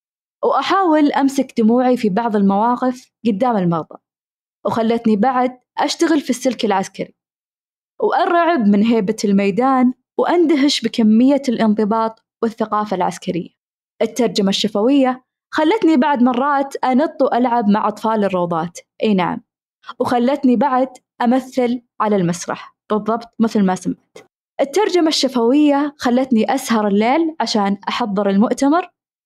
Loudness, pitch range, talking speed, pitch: -17 LUFS, 215-270 Hz, 105 wpm, 245 Hz